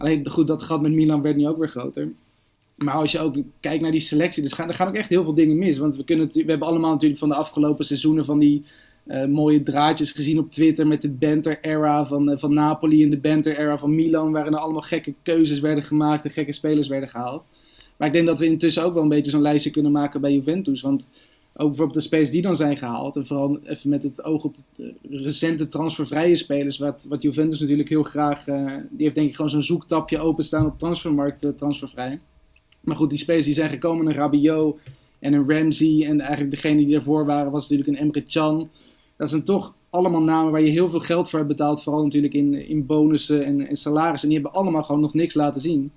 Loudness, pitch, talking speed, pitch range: -21 LUFS, 150 Hz, 235 wpm, 145-155 Hz